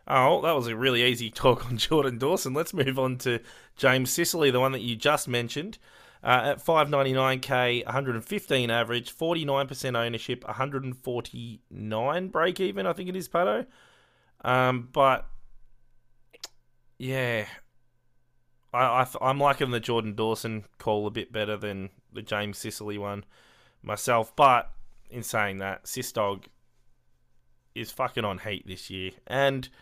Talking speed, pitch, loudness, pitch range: 140 wpm, 125 Hz, -27 LUFS, 110-135 Hz